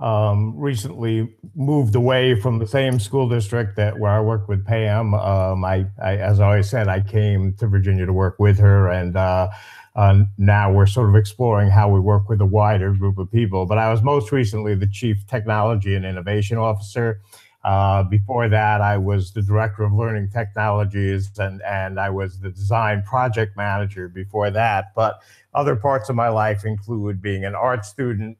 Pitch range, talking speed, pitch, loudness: 100-115 Hz, 190 wpm, 105 Hz, -19 LUFS